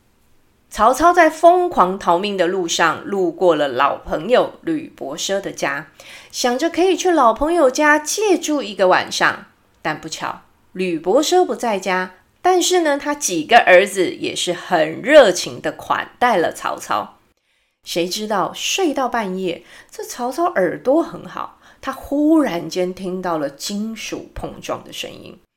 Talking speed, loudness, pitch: 215 characters per minute, -17 LUFS, 245 Hz